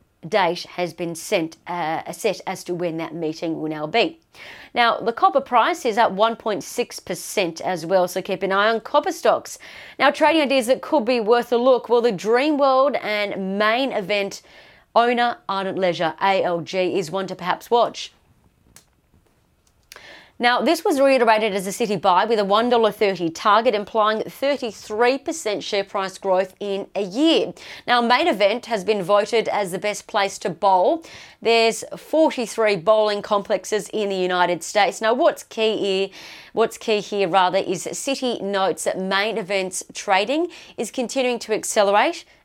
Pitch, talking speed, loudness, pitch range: 215 Hz, 160 wpm, -21 LUFS, 195-240 Hz